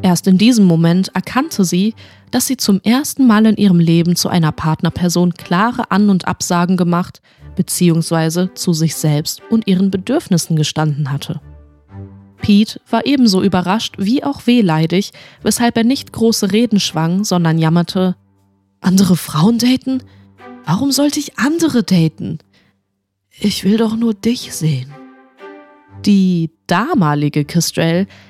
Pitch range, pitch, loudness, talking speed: 155-215 Hz, 180 Hz, -14 LUFS, 135 wpm